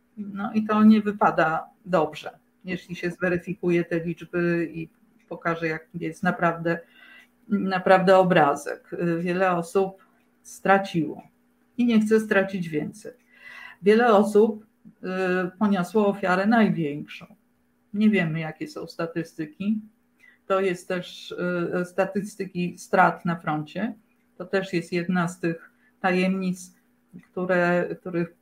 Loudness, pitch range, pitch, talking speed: -24 LUFS, 170-210 Hz, 185 Hz, 110 wpm